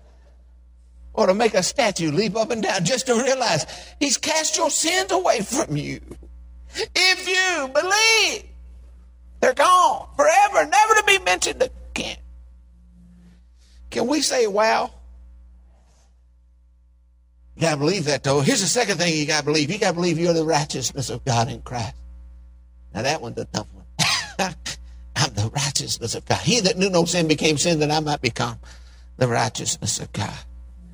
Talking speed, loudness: 165 wpm, -20 LUFS